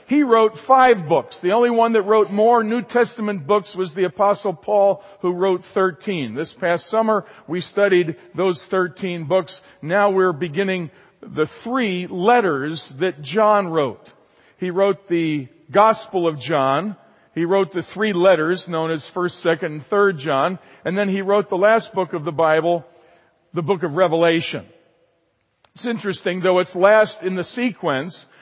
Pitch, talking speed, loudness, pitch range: 185 Hz, 165 wpm, -19 LUFS, 170-210 Hz